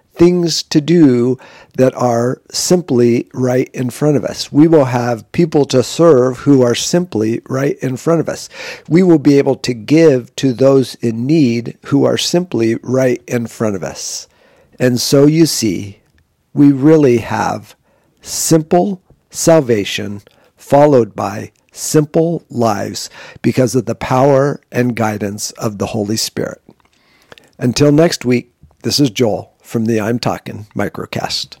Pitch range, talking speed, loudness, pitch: 115-150 Hz, 145 wpm, -14 LUFS, 130 Hz